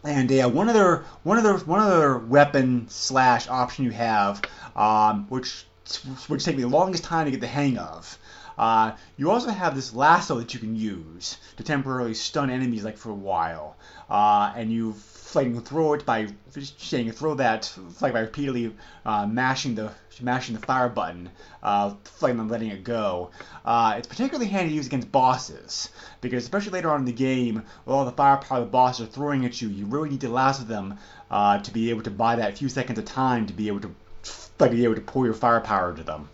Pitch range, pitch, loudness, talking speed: 110-135 Hz, 120 Hz, -24 LUFS, 205 wpm